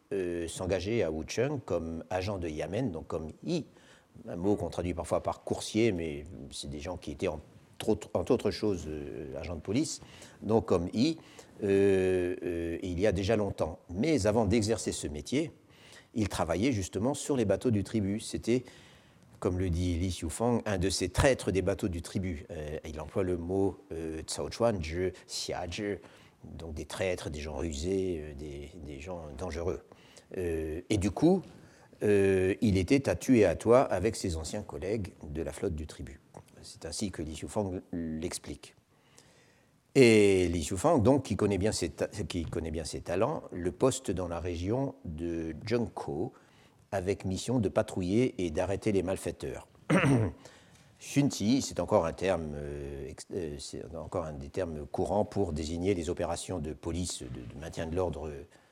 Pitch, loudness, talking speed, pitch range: 95 Hz, -31 LUFS, 170 wpm, 80-105 Hz